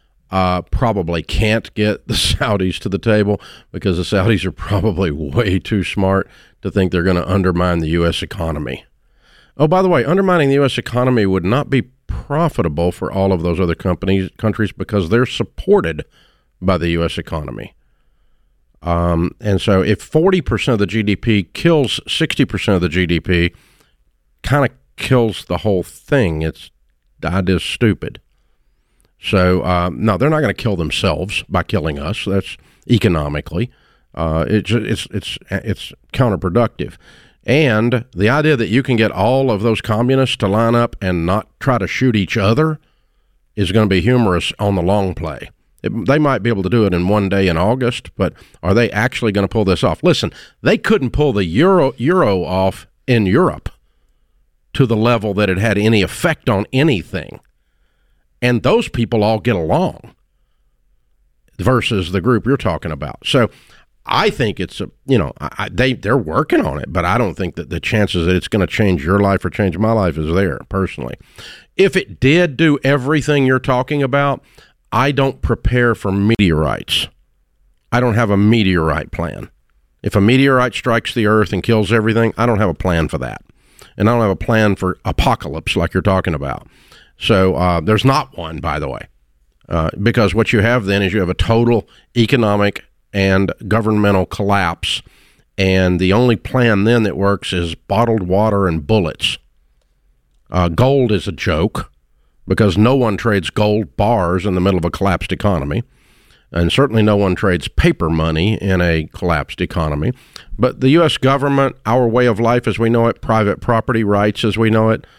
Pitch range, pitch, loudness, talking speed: 90-120 Hz, 100 Hz, -16 LUFS, 180 wpm